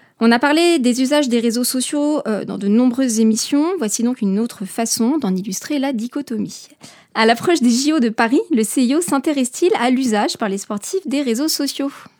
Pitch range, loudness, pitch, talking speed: 225-290 Hz, -17 LUFS, 250 Hz, 185 wpm